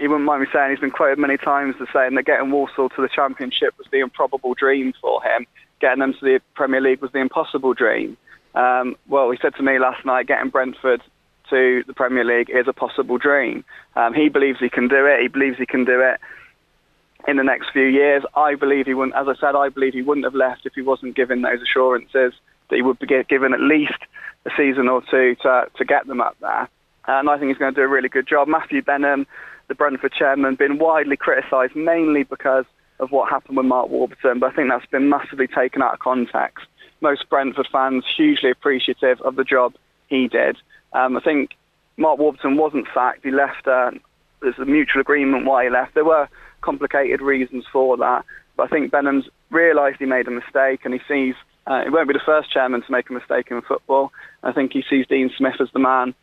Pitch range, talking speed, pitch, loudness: 130-140 Hz, 225 wpm, 135 Hz, -19 LUFS